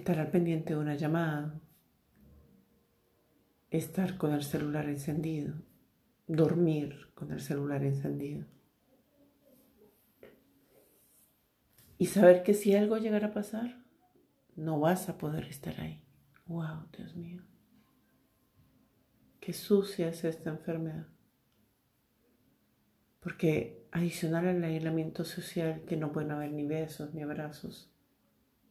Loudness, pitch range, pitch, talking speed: -32 LUFS, 155-180 Hz, 165 Hz, 105 wpm